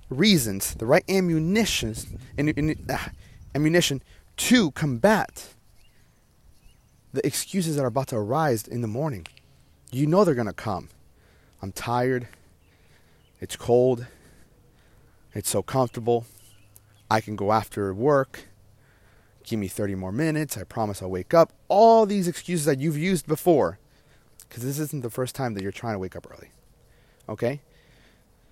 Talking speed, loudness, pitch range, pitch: 140 wpm, -24 LUFS, 100-150 Hz, 120 Hz